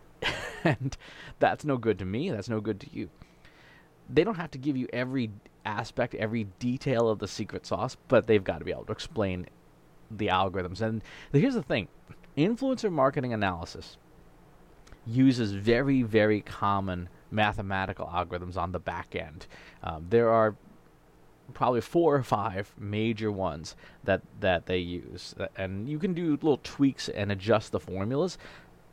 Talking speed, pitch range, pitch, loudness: 155 wpm, 95-125 Hz, 110 Hz, -29 LUFS